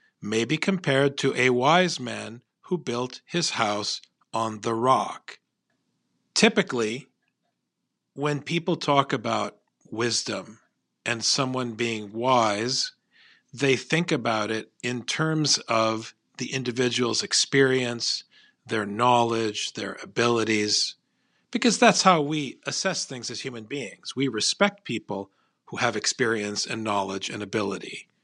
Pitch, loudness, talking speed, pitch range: 125 Hz, -25 LUFS, 120 wpm, 110-140 Hz